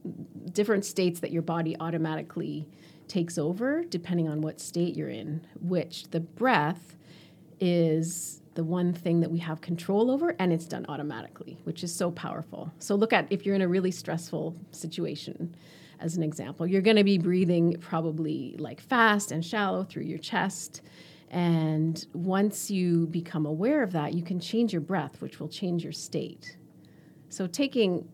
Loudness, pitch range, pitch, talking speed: -29 LUFS, 160-185 Hz, 170 Hz, 170 wpm